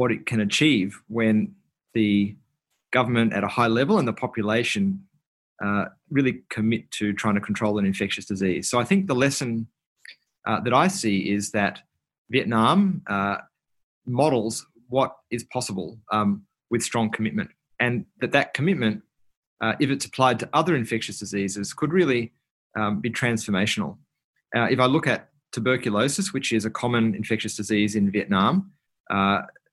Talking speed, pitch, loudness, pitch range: 155 wpm, 115 Hz, -24 LUFS, 105-130 Hz